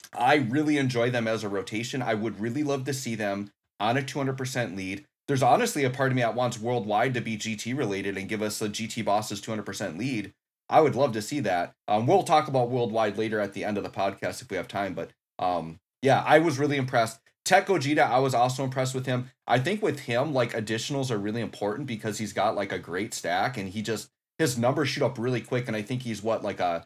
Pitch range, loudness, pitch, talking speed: 110-135 Hz, -27 LUFS, 120 Hz, 240 wpm